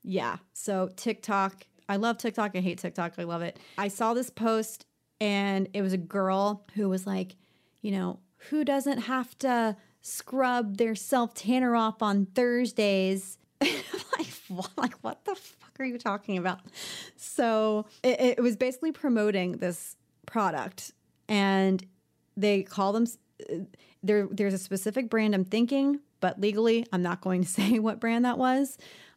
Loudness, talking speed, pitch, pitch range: -29 LUFS, 155 wpm, 210 Hz, 190-235 Hz